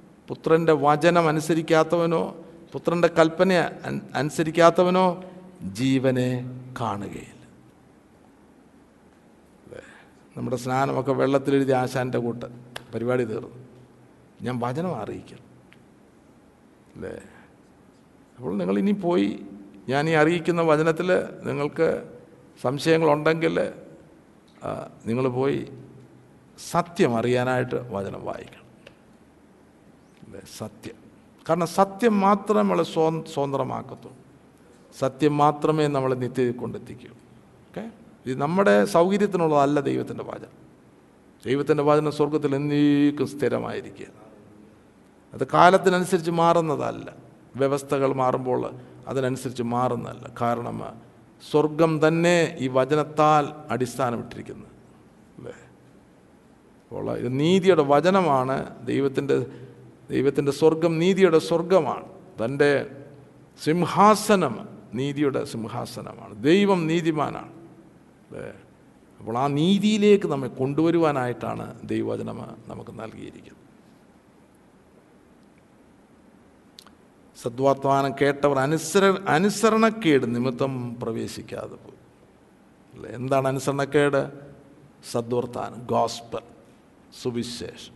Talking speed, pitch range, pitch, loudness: 75 wpm, 125-165 Hz, 145 Hz, -23 LUFS